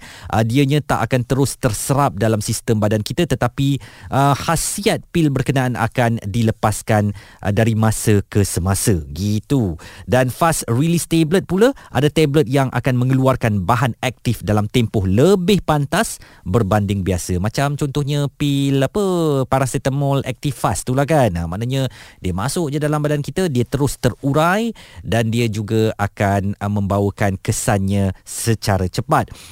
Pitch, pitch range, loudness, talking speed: 125 Hz, 105-140 Hz, -18 LUFS, 140 wpm